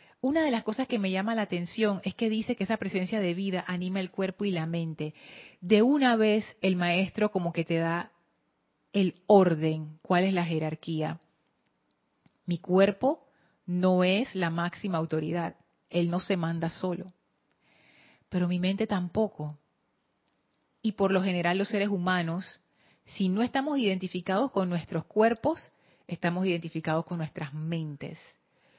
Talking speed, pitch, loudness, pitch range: 150 wpm, 185 Hz, -29 LUFS, 170-205 Hz